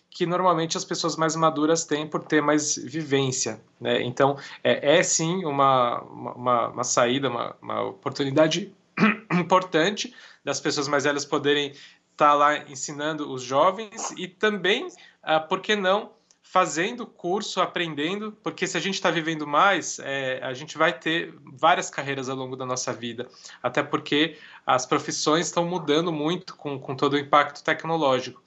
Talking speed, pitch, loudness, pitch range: 160 wpm, 155 Hz, -24 LUFS, 145-180 Hz